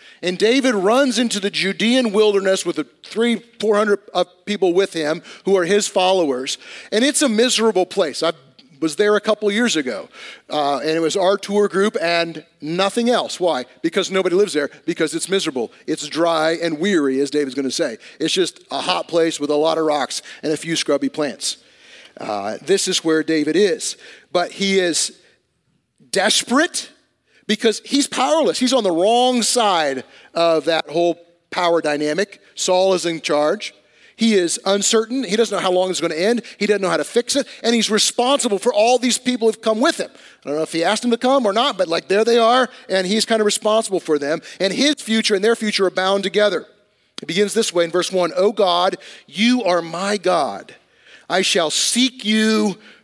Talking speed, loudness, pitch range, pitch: 205 wpm, -18 LUFS, 170-225 Hz, 195 Hz